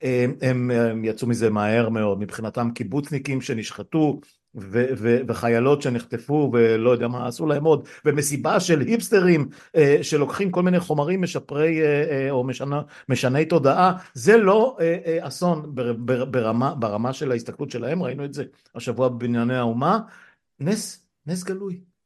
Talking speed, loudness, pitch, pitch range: 125 wpm, -22 LUFS, 140 Hz, 120-160 Hz